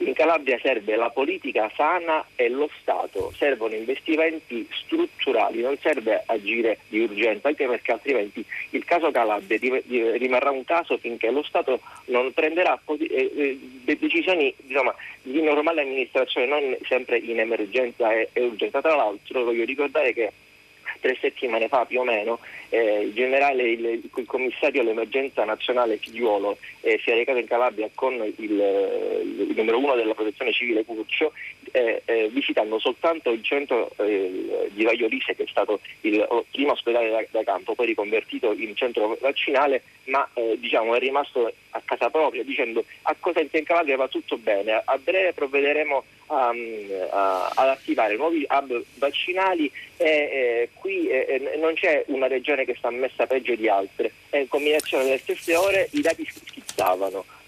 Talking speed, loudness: 155 wpm, -24 LUFS